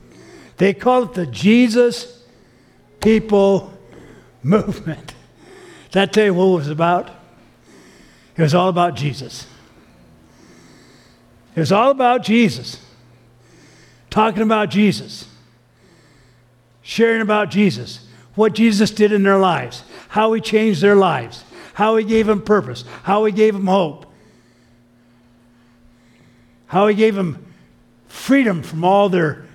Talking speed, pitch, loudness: 120 wpm, 180 Hz, -16 LUFS